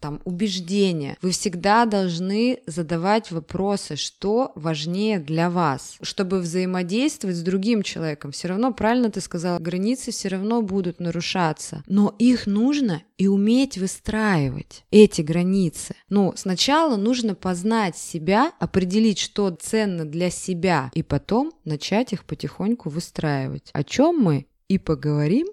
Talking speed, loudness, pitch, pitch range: 130 wpm, -22 LUFS, 190 Hz, 170-215 Hz